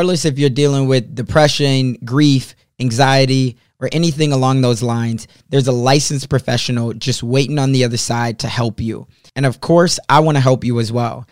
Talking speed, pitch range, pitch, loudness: 190 wpm, 120-140 Hz, 130 Hz, -15 LUFS